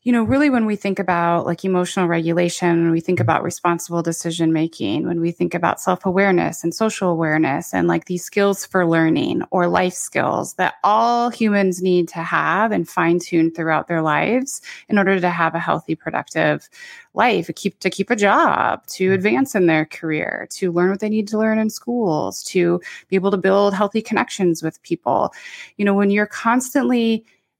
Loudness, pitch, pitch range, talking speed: -19 LUFS, 185 Hz, 170-210 Hz, 190 wpm